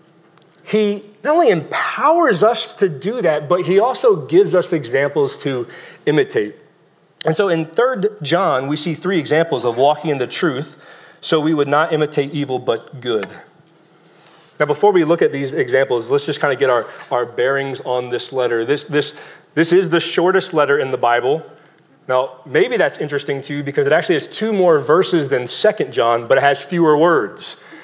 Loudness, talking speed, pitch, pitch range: -17 LUFS, 190 wpm, 165 Hz, 145-210 Hz